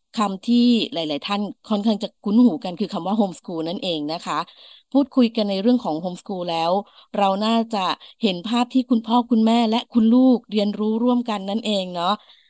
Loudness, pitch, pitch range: -21 LUFS, 210 Hz, 190-240 Hz